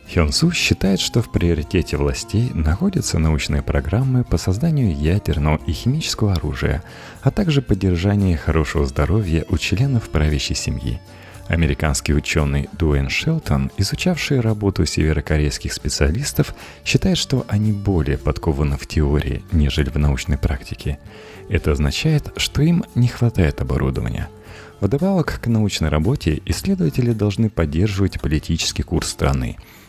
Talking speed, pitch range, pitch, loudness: 120 wpm, 75-110 Hz, 90 Hz, -20 LUFS